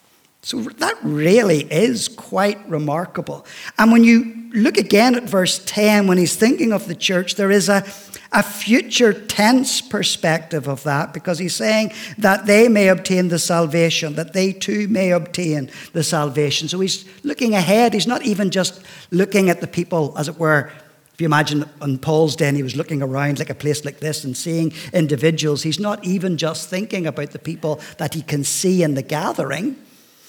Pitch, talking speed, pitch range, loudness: 180 Hz, 185 wpm, 155-205 Hz, -18 LUFS